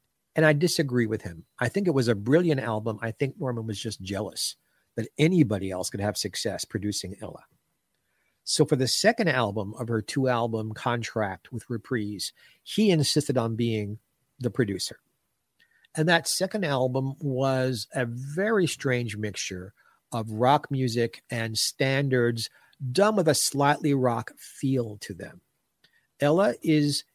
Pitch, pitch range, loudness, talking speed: 125 Hz, 110-145 Hz, -26 LUFS, 150 wpm